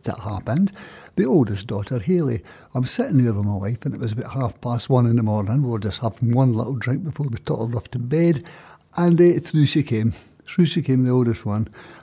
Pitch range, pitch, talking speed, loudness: 115-145 Hz, 125 Hz, 230 wpm, -21 LUFS